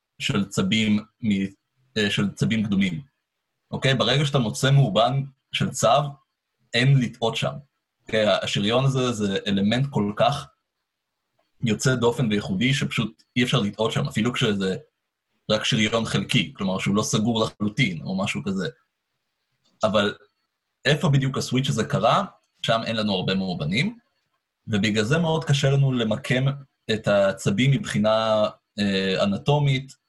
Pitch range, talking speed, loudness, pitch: 105-140 Hz, 130 wpm, -23 LUFS, 120 Hz